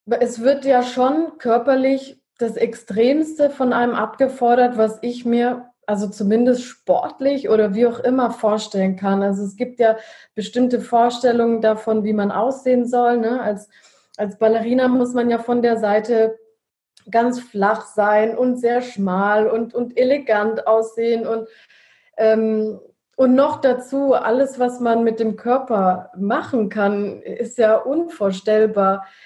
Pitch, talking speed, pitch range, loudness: 235 Hz, 140 wpm, 215-250 Hz, -19 LUFS